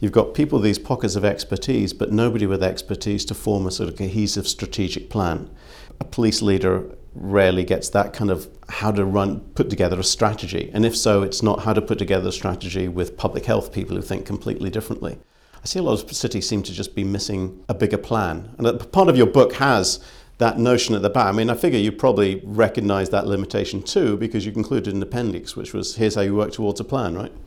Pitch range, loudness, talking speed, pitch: 95-110 Hz, -21 LUFS, 225 wpm, 100 Hz